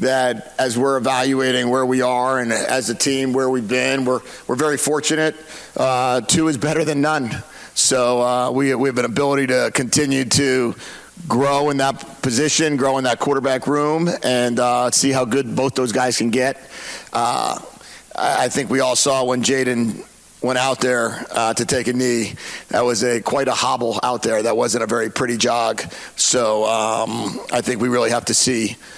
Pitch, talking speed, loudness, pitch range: 130 Hz, 200 wpm, -18 LUFS, 120-135 Hz